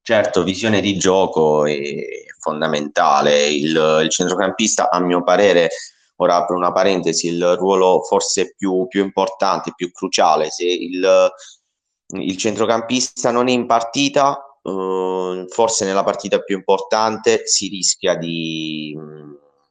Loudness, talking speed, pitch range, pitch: -17 LUFS, 125 wpm, 80-115 Hz, 95 Hz